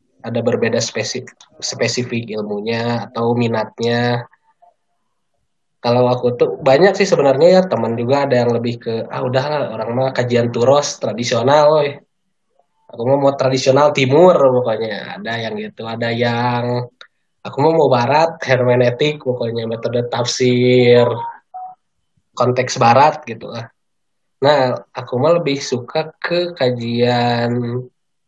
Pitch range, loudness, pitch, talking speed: 120-145 Hz, -16 LUFS, 125 Hz, 125 wpm